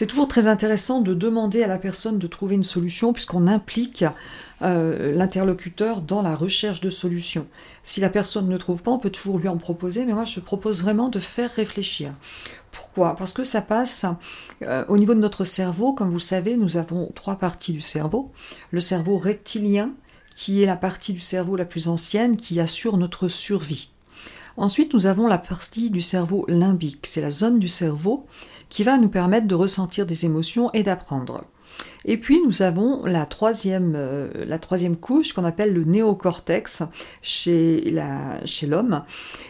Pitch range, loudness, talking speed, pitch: 175-215 Hz, -22 LUFS, 180 wpm, 190 Hz